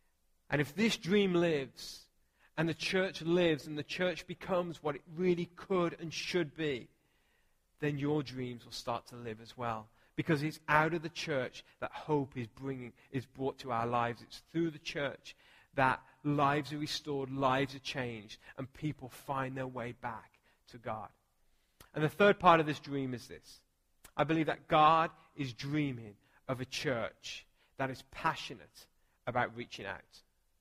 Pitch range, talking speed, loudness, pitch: 125-160 Hz, 170 wpm, -35 LUFS, 140 Hz